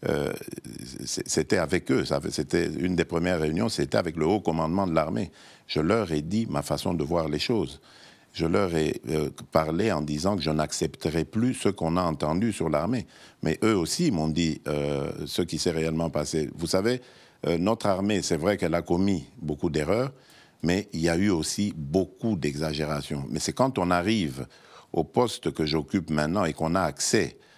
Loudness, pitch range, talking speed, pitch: -27 LUFS, 75-100 Hz, 195 wpm, 85 Hz